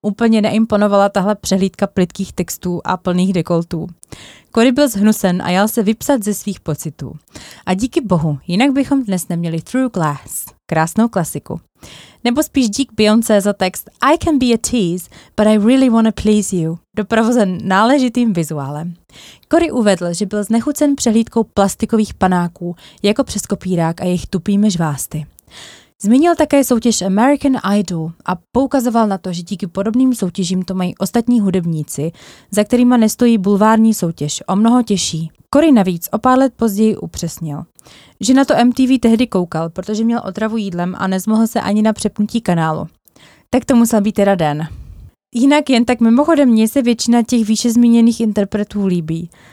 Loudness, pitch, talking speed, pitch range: -15 LUFS, 210 Hz, 160 wpm, 180-235 Hz